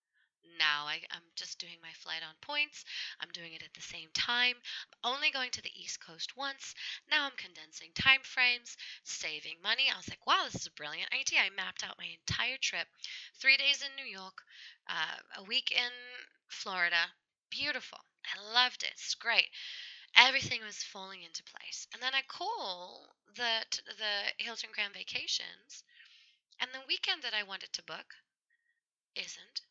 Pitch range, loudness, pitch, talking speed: 190-270 Hz, -33 LUFS, 245 Hz, 170 wpm